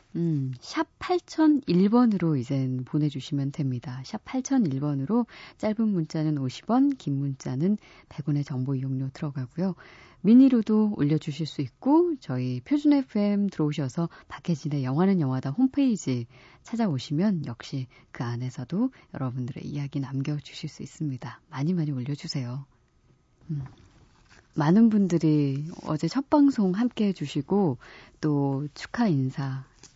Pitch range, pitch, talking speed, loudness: 135-205 Hz, 150 Hz, 275 characters per minute, -26 LUFS